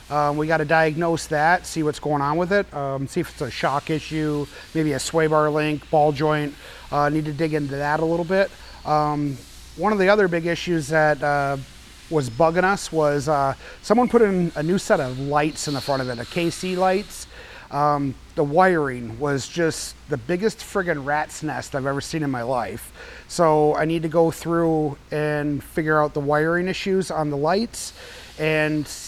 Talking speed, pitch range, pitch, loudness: 210 wpm, 145-170 Hz, 155 Hz, -22 LUFS